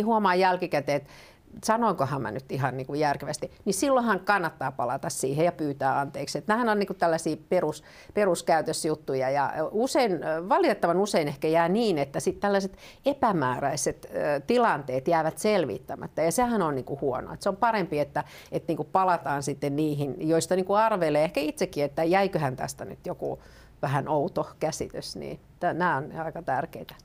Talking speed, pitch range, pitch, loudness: 165 wpm, 145-205 Hz, 165 Hz, -27 LUFS